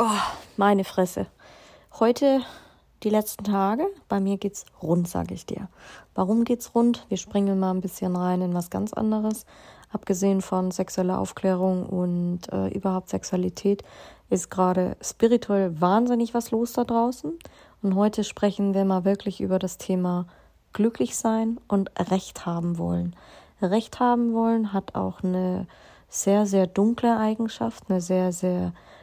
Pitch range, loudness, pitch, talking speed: 185-225 Hz, -25 LUFS, 195 Hz, 145 wpm